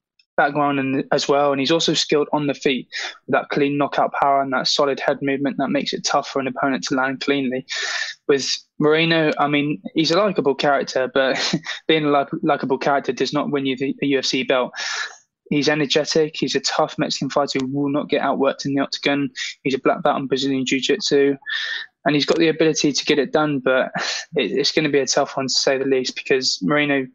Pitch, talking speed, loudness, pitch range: 145 Hz, 215 wpm, -20 LUFS, 135-150 Hz